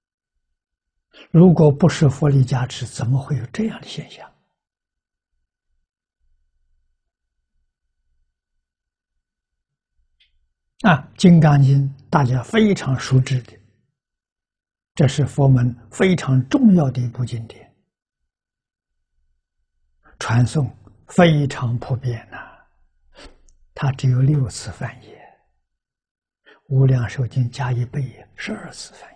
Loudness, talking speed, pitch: -18 LUFS, 140 characters per minute, 120 Hz